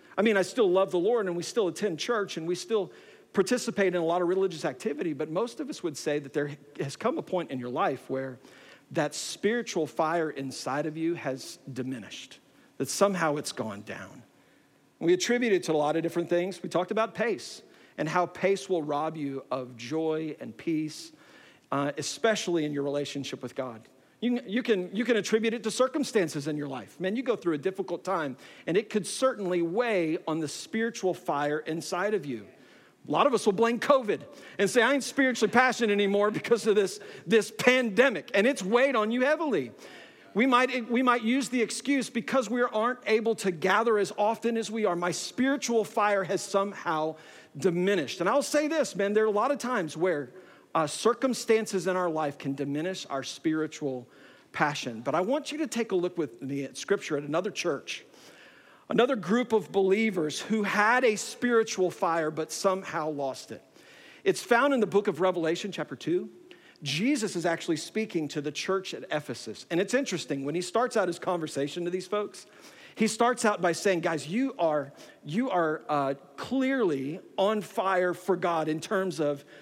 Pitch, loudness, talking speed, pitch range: 190 Hz, -28 LUFS, 195 wpm, 155-225 Hz